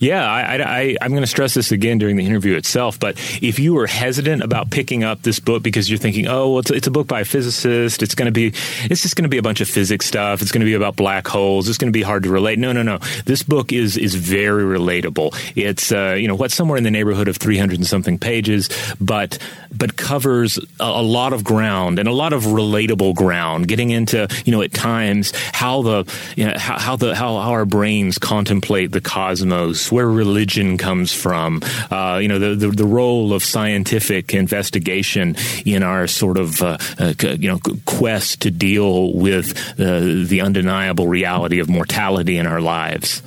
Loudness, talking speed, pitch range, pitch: -17 LUFS, 215 wpm, 95-120 Hz, 105 Hz